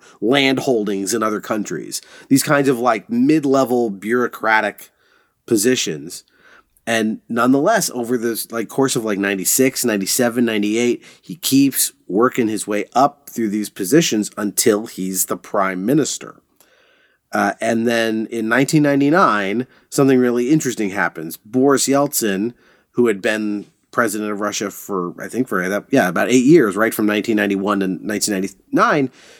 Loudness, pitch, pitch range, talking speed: -18 LUFS, 115 Hz, 105-130 Hz, 140 wpm